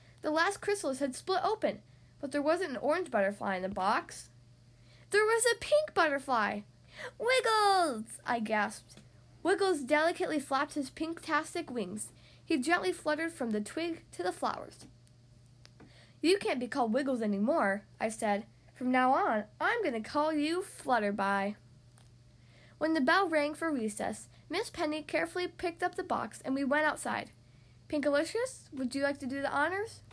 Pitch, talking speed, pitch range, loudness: 285 Hz, 160 wpm, 205-335 Hz, -32 LUFS